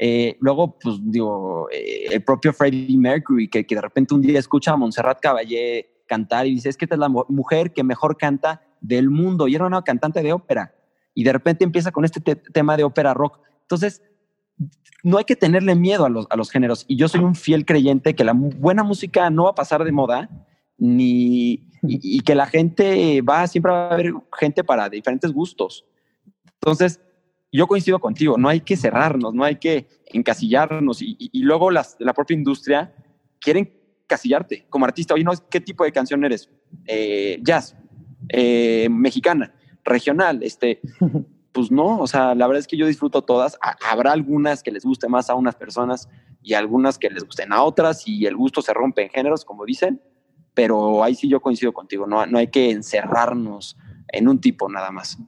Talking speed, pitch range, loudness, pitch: 195 wpm, 125-180 Hz, -19 LUFS, 145 Hz